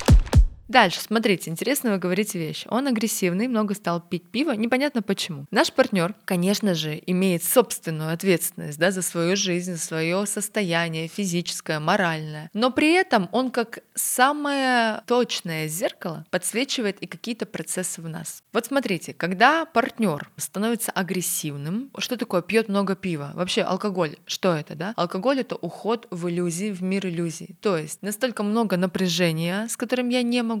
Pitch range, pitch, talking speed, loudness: 175-230 Hz, 195 Hz, 155 wpm, -24 LUFS